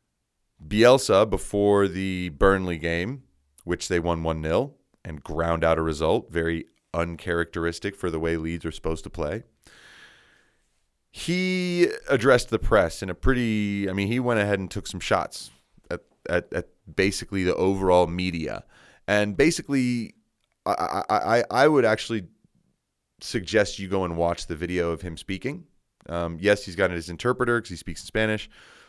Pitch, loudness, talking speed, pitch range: 95 Hz, -25 LUFS, 155 wpm, 85-105 Hz